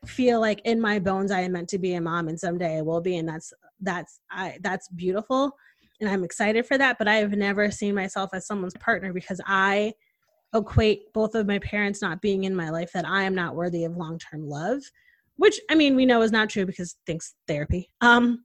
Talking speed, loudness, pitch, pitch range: 225 wpm, -25 LUFS, 195 Hz, 180-225 Hz